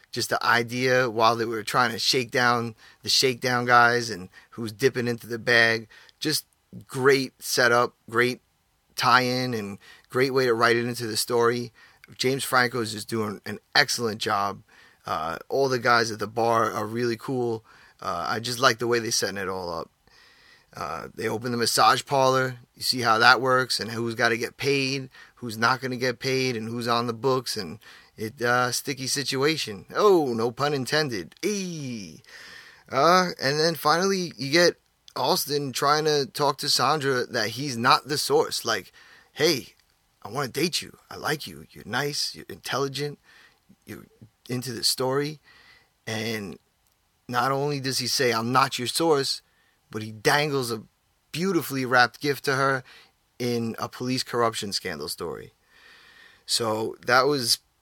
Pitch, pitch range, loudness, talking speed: 125 Hz, 115-135 Hz, -24 LUFS, 170 wpm